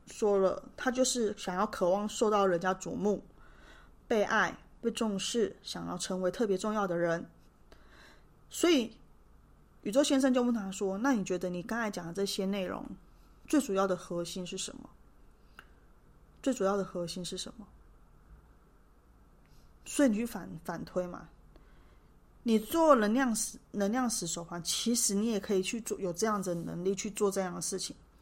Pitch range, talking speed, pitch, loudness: 185-230 Hz, 235 characters per minute, 205 Hz, -32 LUFS